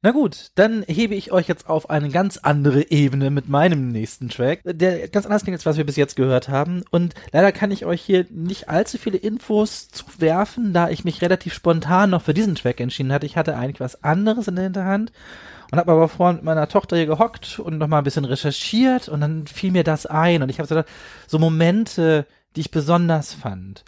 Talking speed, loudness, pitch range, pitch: 220 wpm, -20 LUFS, 150-190 Hz, 165 Hz